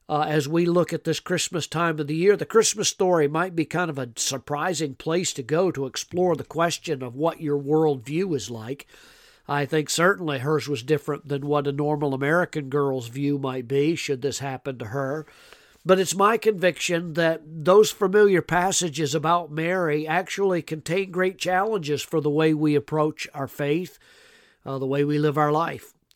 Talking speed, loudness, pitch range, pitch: 190 wpm, -24 LUFS, 145-180 Hz, 155 Hz